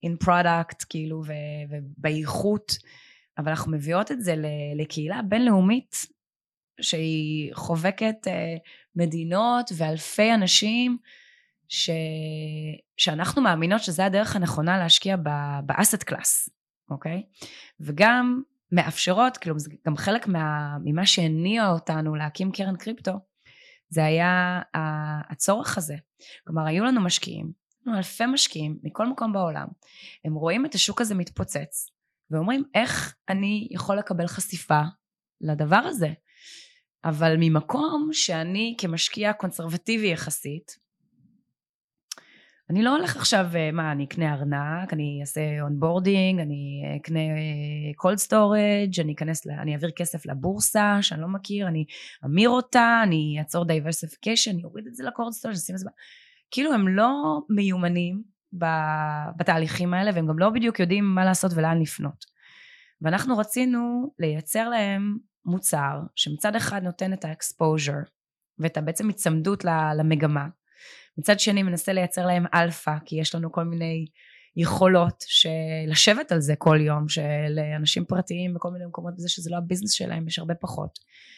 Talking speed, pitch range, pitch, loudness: 130 wpm, 155-205 Hz, 175 Hz, -24 LUFS